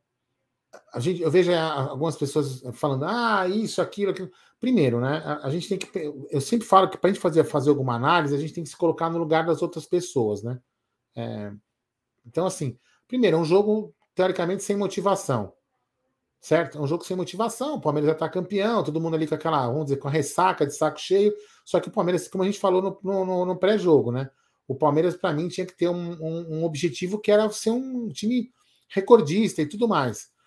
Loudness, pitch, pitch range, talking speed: -24 LUFS, 170 Hz, 150-195 Hz, 205 wpm